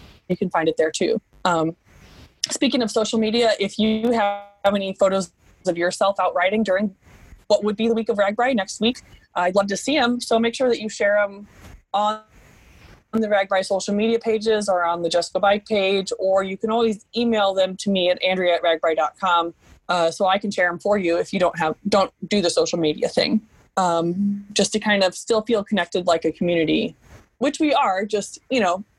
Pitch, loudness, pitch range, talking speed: 200 Hz, -21 LUFS, 180-220 Hz, 205 wpm